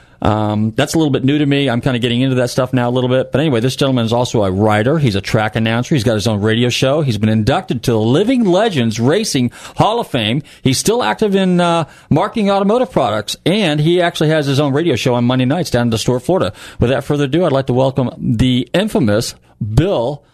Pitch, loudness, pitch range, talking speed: 130 Hz, -15 LUFS, 120-155 Hz, 240 wpm